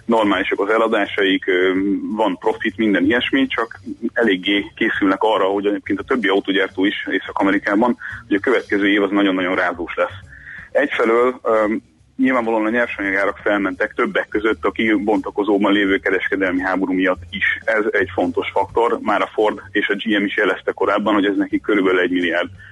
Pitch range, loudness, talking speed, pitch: 95-115 Hz, -18 LUFS, 155 wpm, 100 Hz